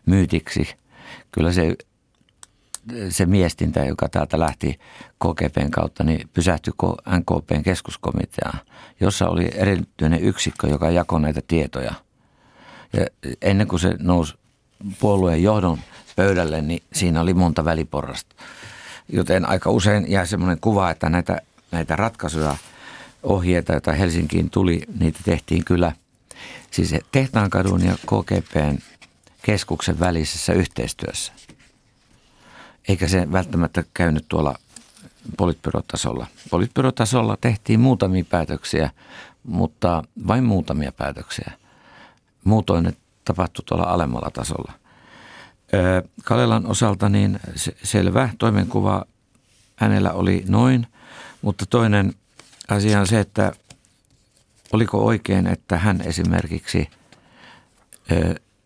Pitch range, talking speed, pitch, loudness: 85-105 Hz, 100 wpm, 90 Hz, -21 LUFS